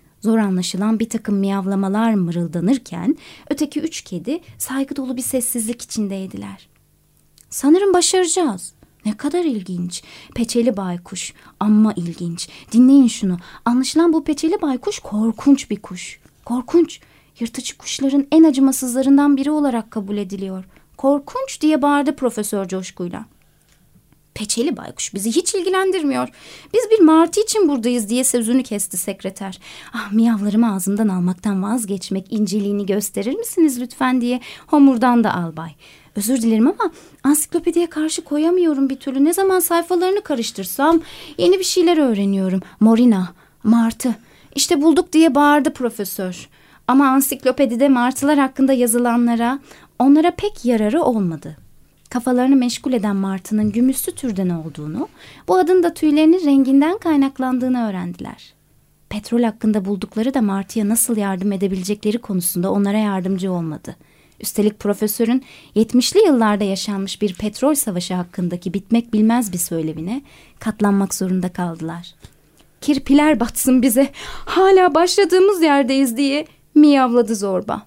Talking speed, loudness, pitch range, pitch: 120 wpm, -18 LUFS, 200-285 Hz, 240 Hz